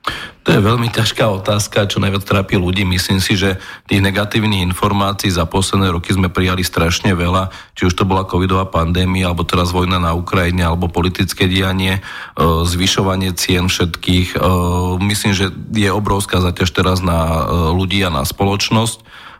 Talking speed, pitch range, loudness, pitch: 155 wpm, 90-100 Hz, -15 LUFS, 95 Hz